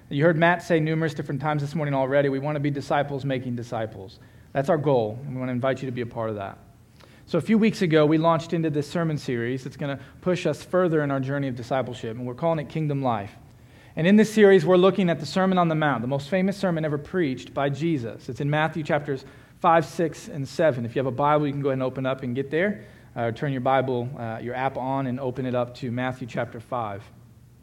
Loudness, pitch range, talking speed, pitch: -24 LUFS, 125-160 Hz, 260 wpm, 140 Hz